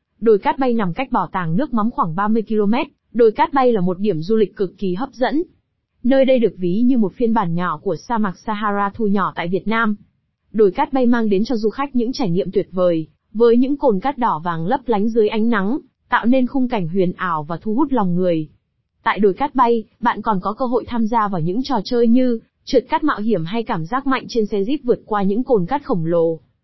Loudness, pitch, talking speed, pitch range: -19 LUFS, 220 Hz, 250 wpm, 195-250 Hz